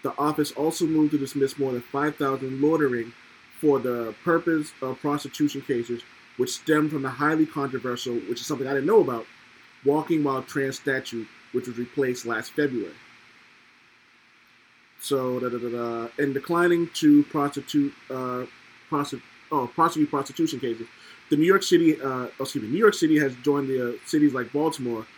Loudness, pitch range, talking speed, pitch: -25 LUFS, 125-150 Hz, 155 wpm, 140 Hz